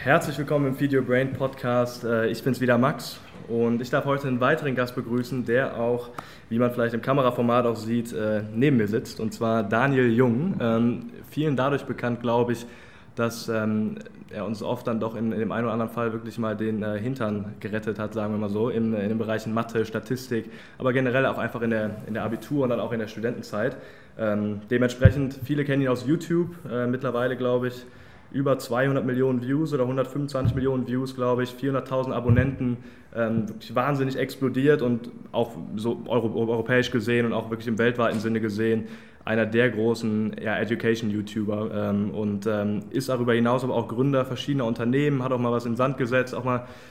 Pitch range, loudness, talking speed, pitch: 115-130 Hz, -25 LUFS, 185 wpm, 120 Hz